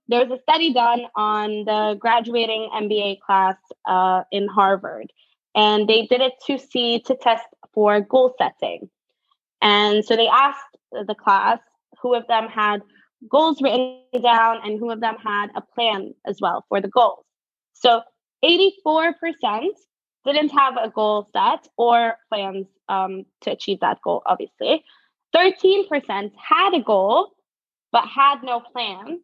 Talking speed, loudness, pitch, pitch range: 150 wpm, -20 LUFS, 235 Hz, 210-275 Hz